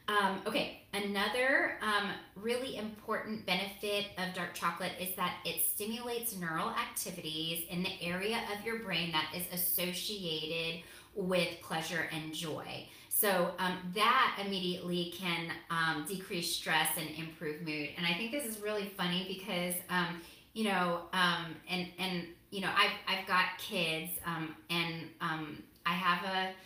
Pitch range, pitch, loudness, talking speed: 170-200 Hz, 180 Hz, -34 LUFS, 150 wpm